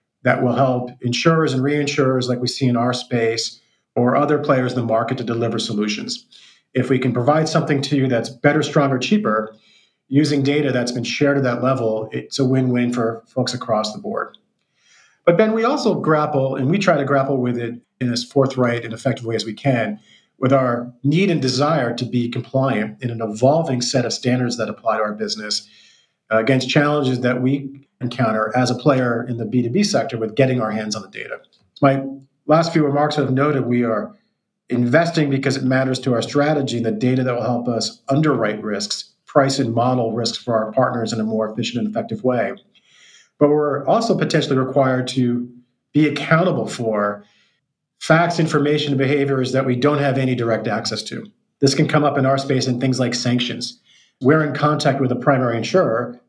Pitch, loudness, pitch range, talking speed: 130 Hz, -19 LUFS, 120-145 Hz, 195 wpm